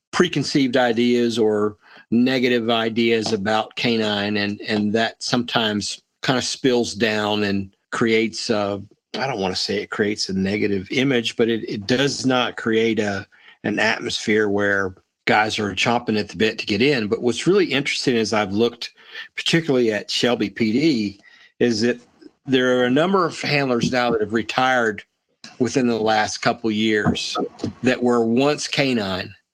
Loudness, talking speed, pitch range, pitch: -20 LUFS, 160 wpm, 105-125 Hz, 115 Hz